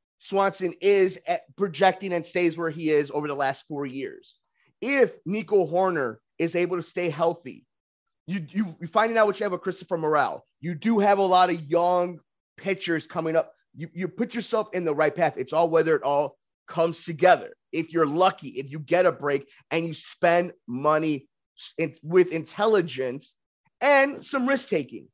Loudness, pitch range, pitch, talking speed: -25 LUFS, 160-195 Hz, 175 Hz, 185 wpm